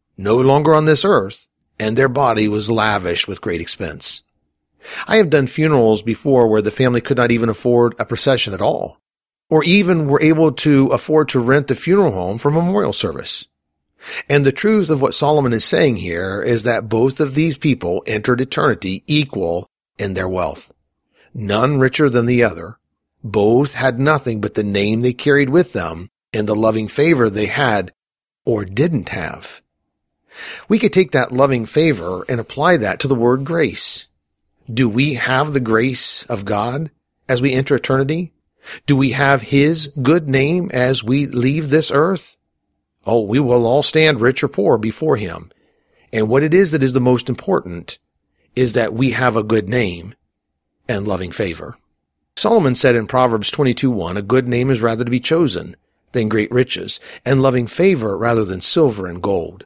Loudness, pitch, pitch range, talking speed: -16 LUFS, 125 Hz, 105-145 Hz, 175 wpm